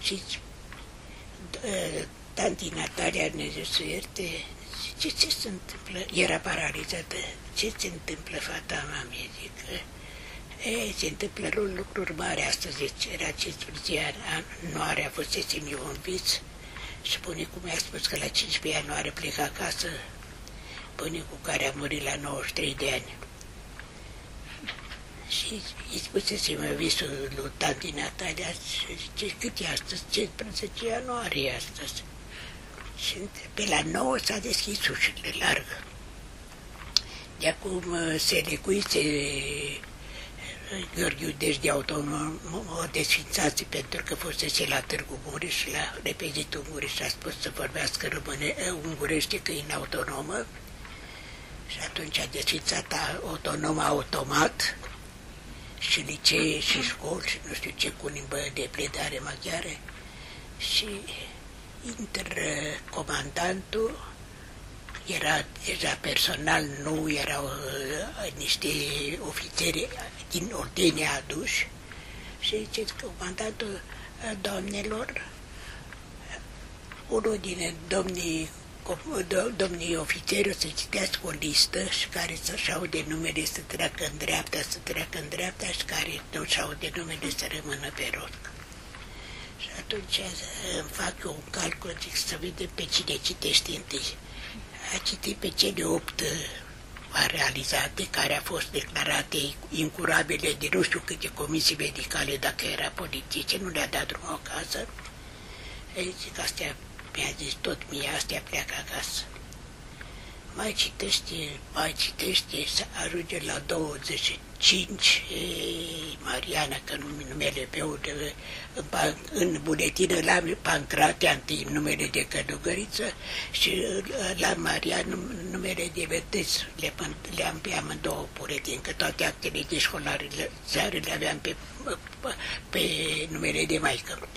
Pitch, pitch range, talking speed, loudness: 170 Hz, 150-195 Hz, 125 wpm, -29 LUFS